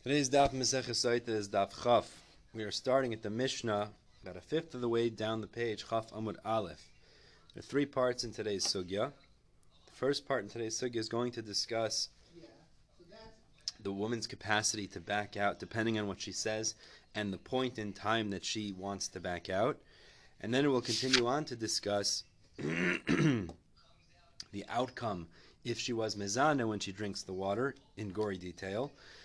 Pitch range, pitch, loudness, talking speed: 100-120 Hz, 110 Hz, -35 LUFS, 175 wpm